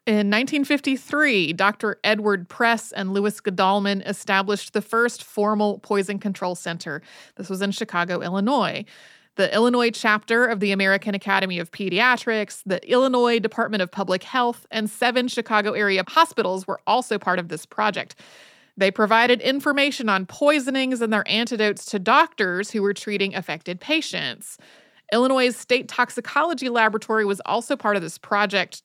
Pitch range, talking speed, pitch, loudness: 195-240 Hz, 150 wpm, 210 Hz, -21 LUFS